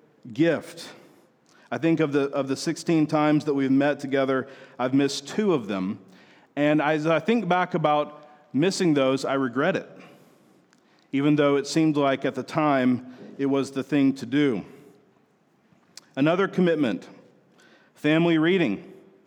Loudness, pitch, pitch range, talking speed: -24 LUFS, 145 Hz, 135-155 Hz, 145 wpm